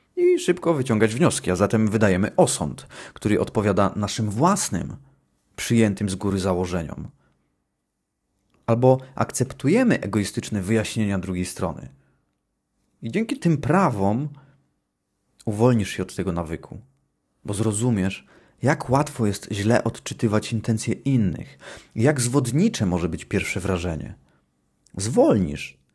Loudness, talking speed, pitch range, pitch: -22 LUFS, 110 wpm, 95-130 Hz, 110 Hz